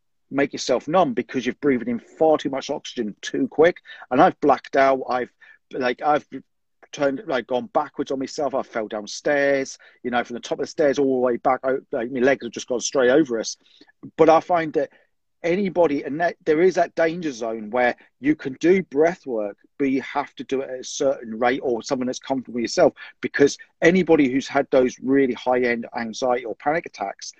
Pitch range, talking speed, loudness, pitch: 125-150 Hz, 210 wpm, -22 LUFS, 135 Hz